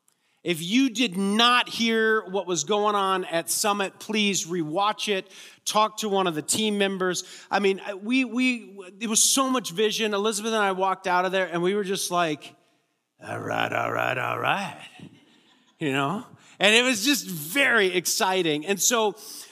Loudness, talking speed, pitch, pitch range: -23 LUFS, 180 wpm, 200 Hz, 185-220 Hz